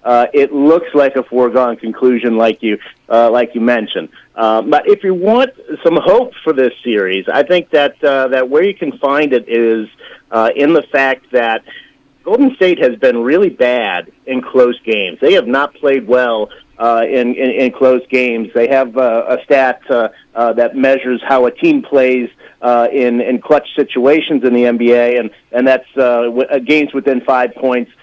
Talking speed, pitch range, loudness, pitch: 190 wpm, 120-140 Hz, -12 LUFS, 130 Hz